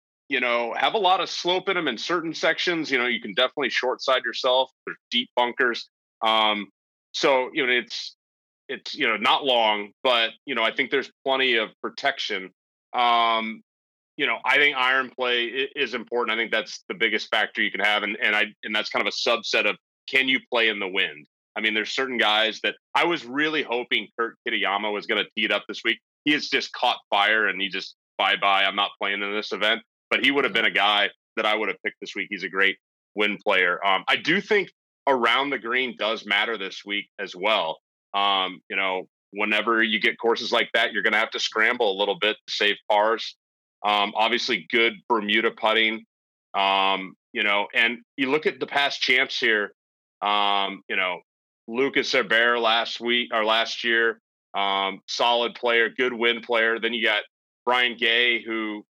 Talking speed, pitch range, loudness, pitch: 205 wpm, 100-120 Hz, -23 LUFS, 110 Hz